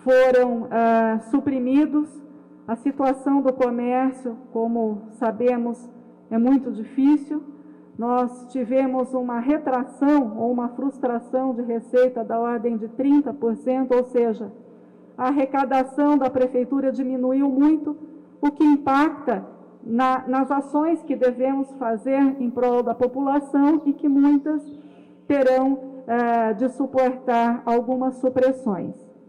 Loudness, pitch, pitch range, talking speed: -22 LUFS, 255 Hz, 240-275 Hz, 115 wpm